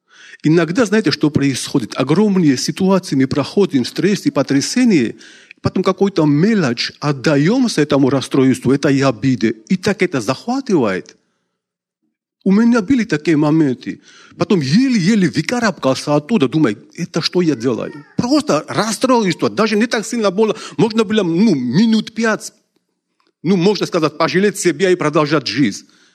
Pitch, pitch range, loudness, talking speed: 175 Hz, 145-215 Hz, -15 LUFS, 135 wpm